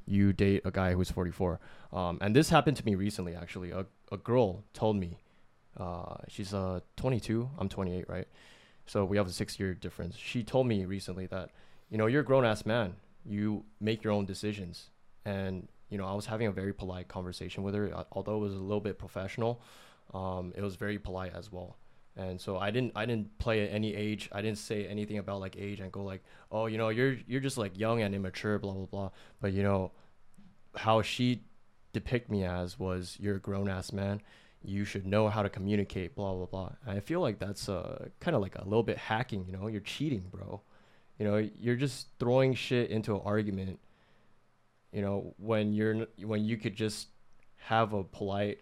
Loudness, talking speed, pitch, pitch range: -34 LUFS, 210 wpm, 100 Hz, 95-110 Hz